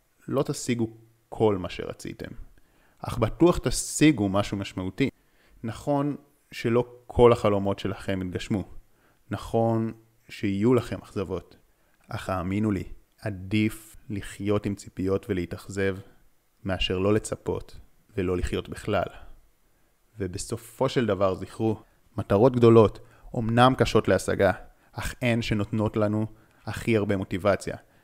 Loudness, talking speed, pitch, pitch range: -26 LUFS, 105 wpm, 110 Hz, 100-115 Hz